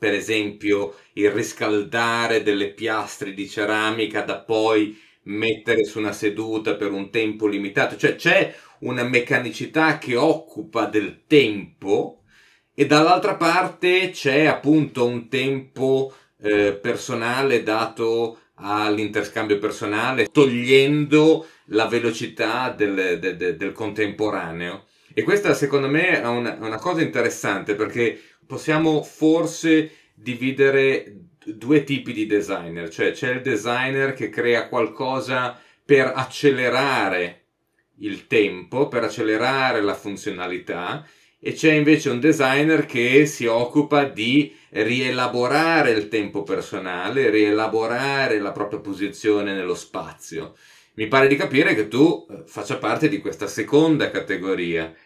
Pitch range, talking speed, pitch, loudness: 105-145 Hz, 120 wpm, 120 Hz, -21 LUFS